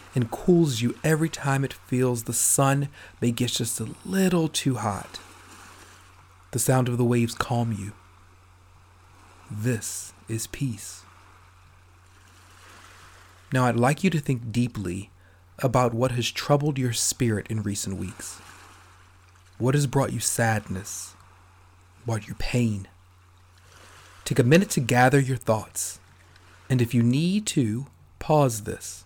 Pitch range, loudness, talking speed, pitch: 90-125 Hz, -25 LUFS, 130 wpm, 105 Hz